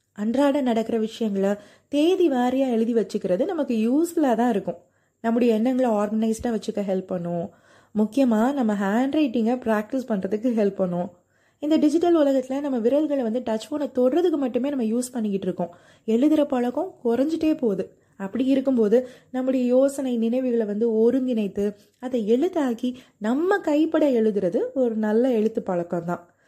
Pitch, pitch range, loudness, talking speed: 240 Hz, 215-270 Hz, -23 LUFS, 135 wpm